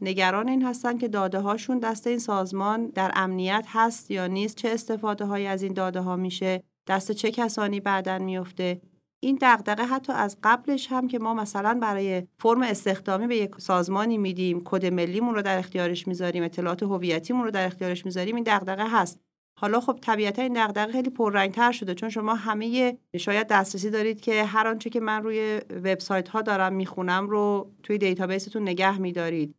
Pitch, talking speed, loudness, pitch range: 205 Hz, 175 wpm, -26 LUFS, 185-225 Hz